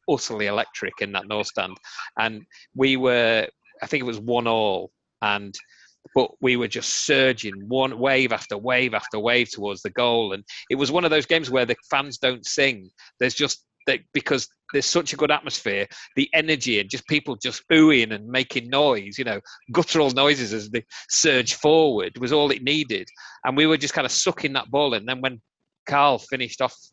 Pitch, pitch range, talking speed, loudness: 130 Hz, 115-145 Hz, 195 wpm, -22 LUFS